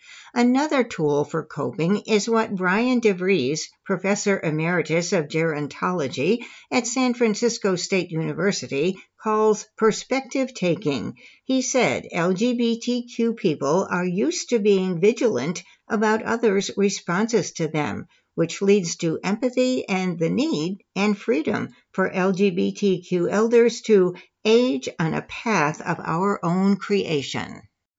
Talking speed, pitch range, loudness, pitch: 120 wpm, 180-230 Hz, -22 LUFS, 200 Hz